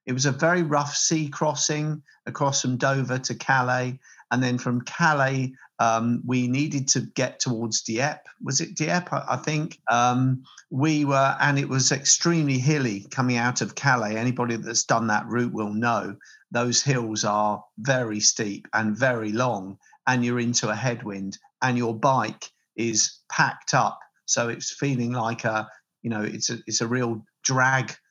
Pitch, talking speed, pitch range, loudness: 125 Hz, 170 wpm, 115-135 Hz, -24 LUFS